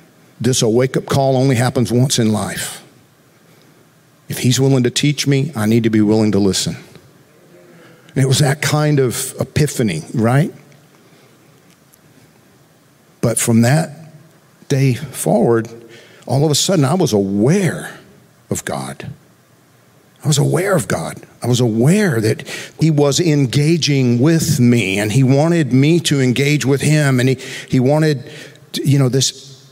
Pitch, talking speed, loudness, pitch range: 140 Hz, 150 wpm, -15 LUFS, 125-150 Hz